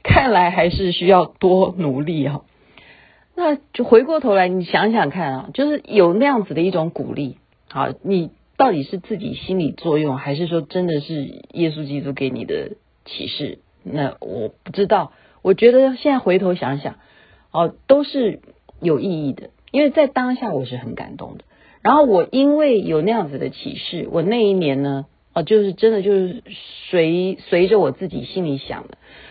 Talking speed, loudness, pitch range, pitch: 260 characters per minute, -18 LUFS, 155-225 Hz, 185 Hz